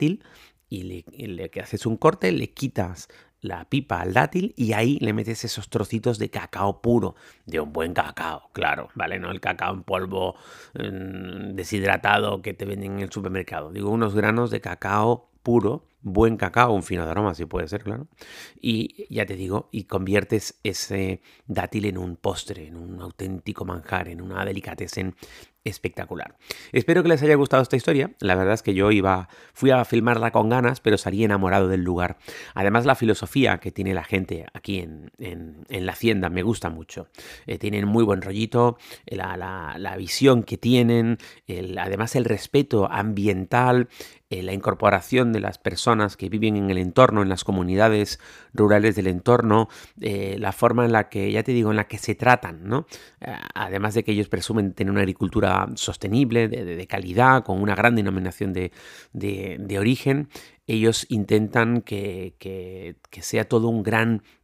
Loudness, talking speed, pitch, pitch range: -23 LUFS, 180 wpm, 105 Hz, 95-115 Hz